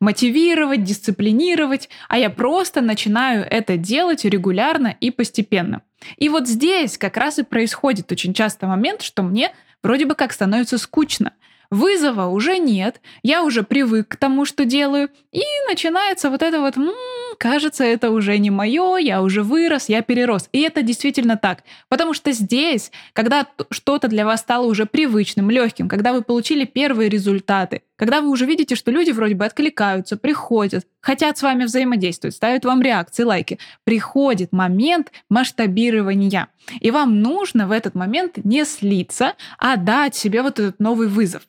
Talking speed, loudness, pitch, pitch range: 160 wpm, -18 LUFS, 240 Hz, 215-285 Hz